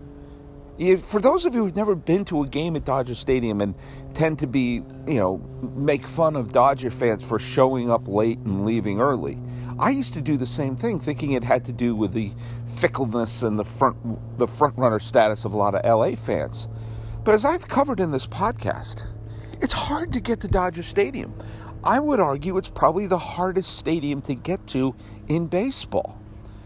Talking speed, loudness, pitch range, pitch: 195 wpm, -23 LUFS, 110-160 Hz, 130 Hz